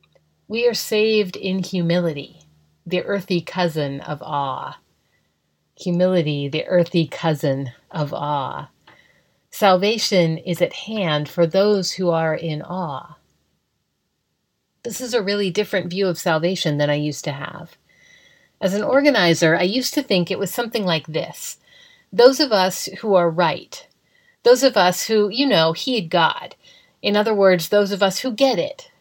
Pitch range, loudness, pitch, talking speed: 160-210 Hz, -20 LUFS, 185 Hz, 155 wpm